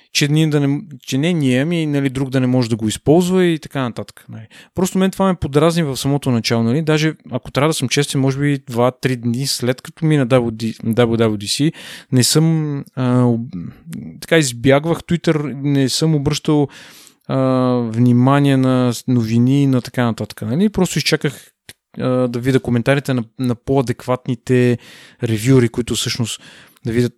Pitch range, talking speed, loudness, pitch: 120-150 Hz, 165 wpm, -17 LUFS, 130 Hz